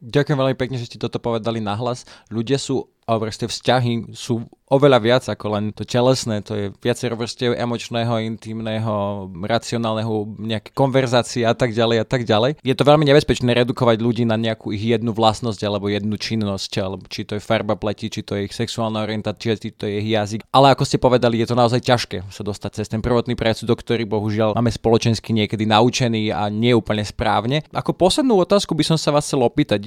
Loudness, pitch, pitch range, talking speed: -20 LUFS, 115 Hz, 110-125 Hz, 200 wpm